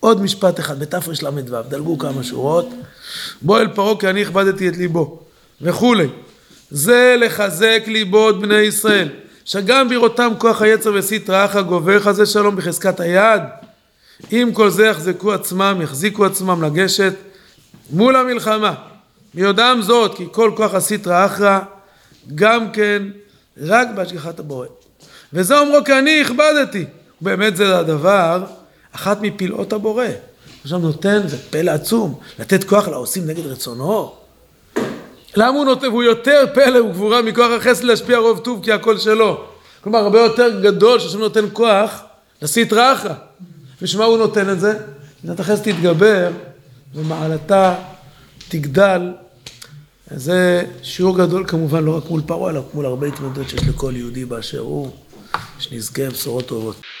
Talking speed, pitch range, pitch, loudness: 140 wpm, 160-220 Hz, 195 Hz, -15 LUFS